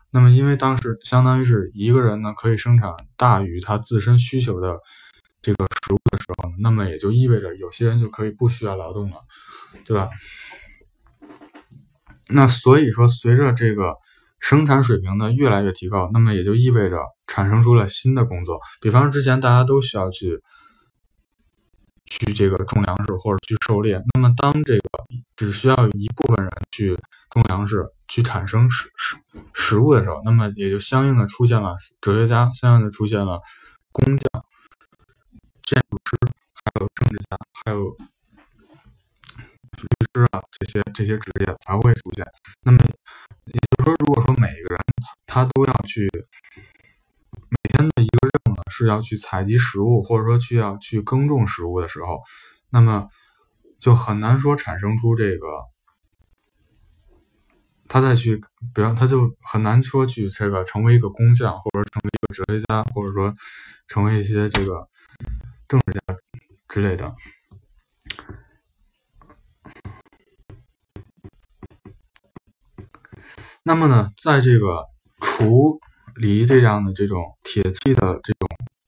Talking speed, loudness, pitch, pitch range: 220 characters per minute, -19 LUFS, 110 Hz, 100-120 Hz